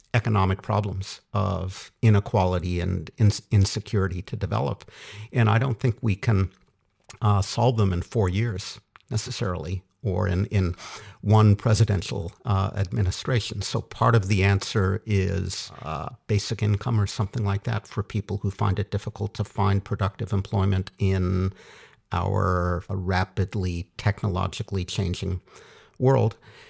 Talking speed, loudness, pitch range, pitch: 130 wpm, -25 LUFS, 95-110 Hz, 100 Hz